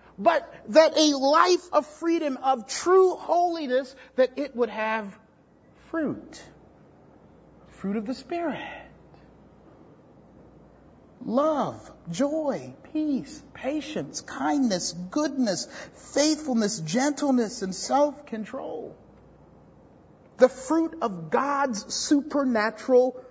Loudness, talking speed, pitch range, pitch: -25 LUFS, 85 wpm, 240-305 Hz, 275 Hz